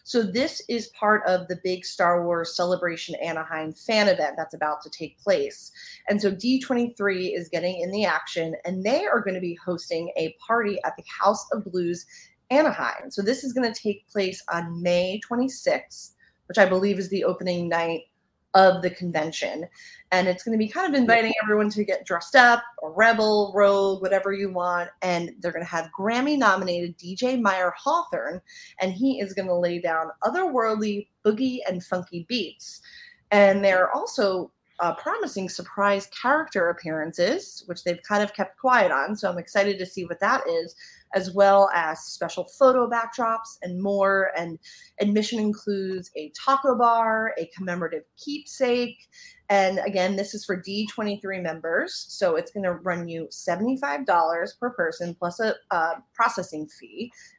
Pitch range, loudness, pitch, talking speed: 175-230 Hz, -24 LUFS, 195 Hz, 170 wpm